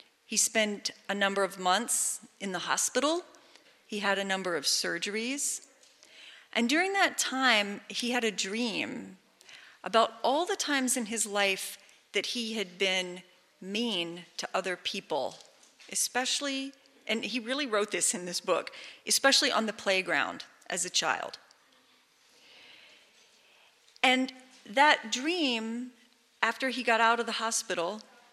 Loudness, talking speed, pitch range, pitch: -29 LUFS, 135 wpm, 200-255 Hz, 225 Hz